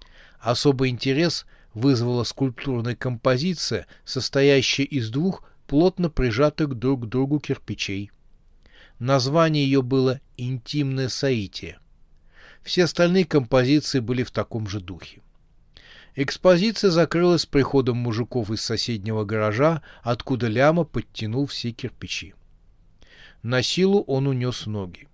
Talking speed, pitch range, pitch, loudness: 105 wpm, 115-145 Hz, 130 Hz, -23 LUFS